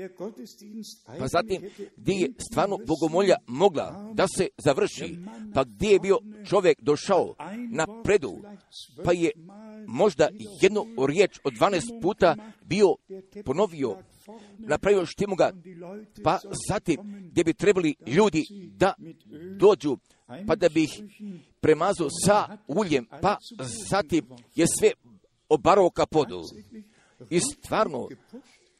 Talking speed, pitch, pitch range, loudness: 115 wpm, 195 Hz, 165-210 Hz, -25 LUFS